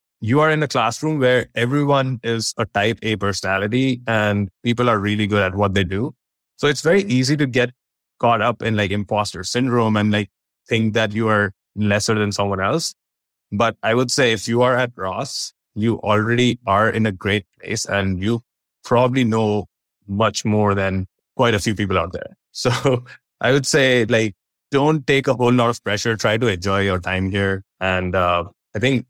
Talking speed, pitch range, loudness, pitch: 195 wpm, 100-125 Hz, -19 LUFS, 110 Hz